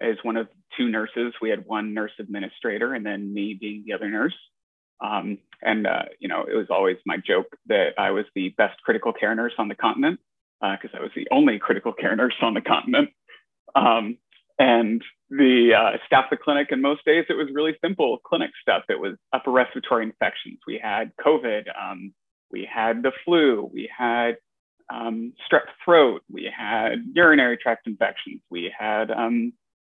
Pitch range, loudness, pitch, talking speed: 110-150 Hz, -23 LUFS, 120 Hz, 185 wpm